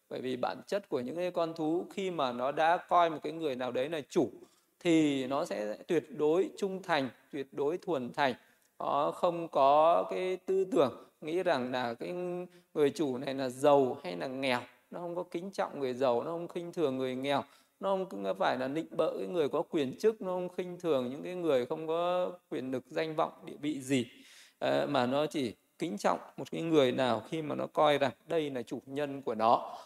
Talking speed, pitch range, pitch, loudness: 220 wpm, 135-180 Hz, 160 Hz, -32 LUFS